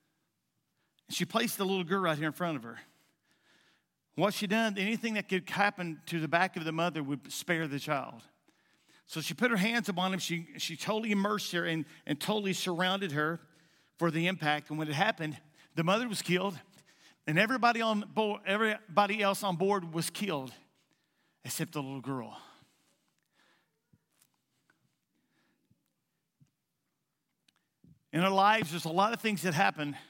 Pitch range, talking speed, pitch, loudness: 160-200 Hz, 160 wpm, 180 Hz, -31 LUFS